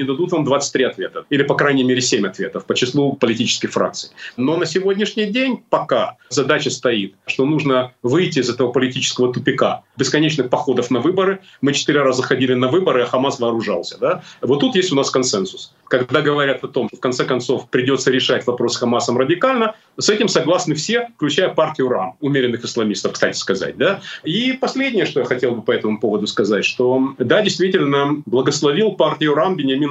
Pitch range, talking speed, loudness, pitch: 125-180 Hz, 185 wpm, -18 LUFS, 140 Hz